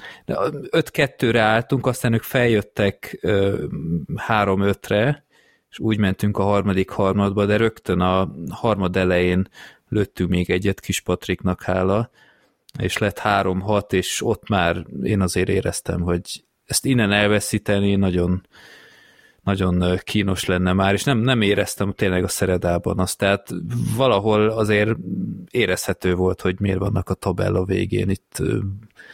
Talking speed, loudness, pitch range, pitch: 130 wpm, -21 LUFS, 90-105 Hz, 100 Hz